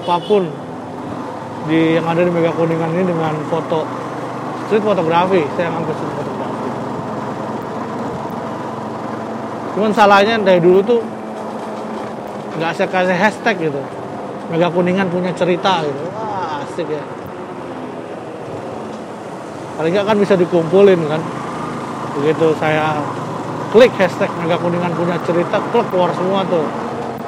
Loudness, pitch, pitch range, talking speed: -17 LUFS, 175 Hz, 160-190 Hz, 110 wpm